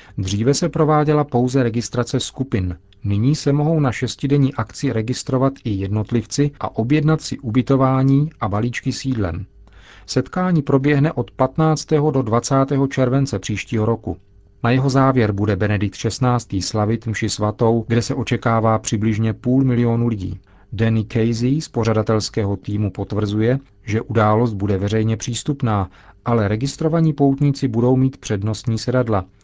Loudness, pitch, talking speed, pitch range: -19 LUFS, 120 Hz, 135 wpm, 105-135 Hz